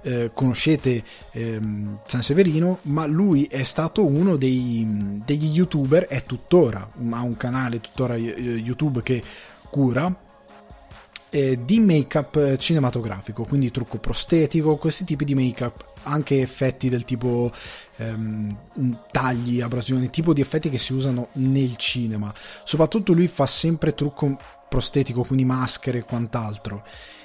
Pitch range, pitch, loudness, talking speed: 120-150 Hz, 130 Hz, -22 LUFS, 130 wpm